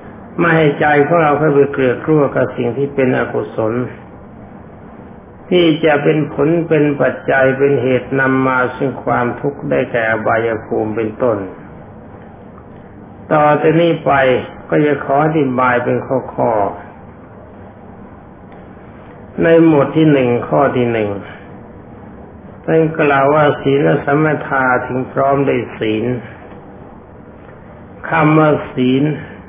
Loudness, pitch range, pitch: -14 LUFS, 120-150 Hz, 135 Hz